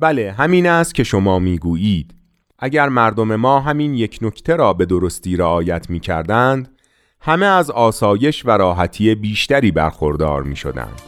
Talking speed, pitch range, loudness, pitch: 135 wpm, 90-140 Hz, -16 LUFS, 110 Hz